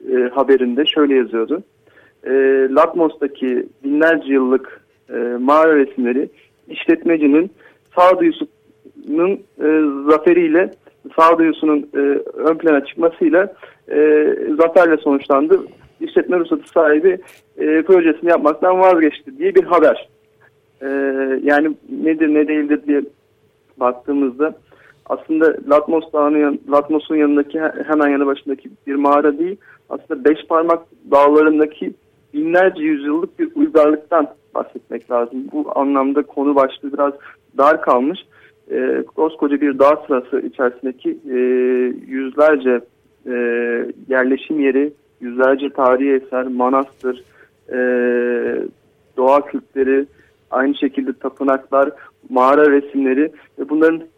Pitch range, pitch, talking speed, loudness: 135-160 Hz, 145 Hz, 105 wpm, -16 LUFS